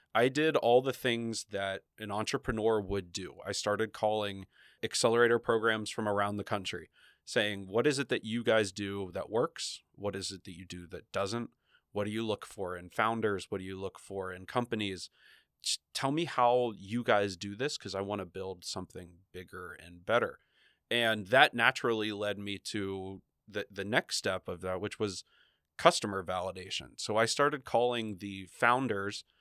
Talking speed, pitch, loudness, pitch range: 185 wpm, 105 Hz, -32 LUFS, 95-115 Hz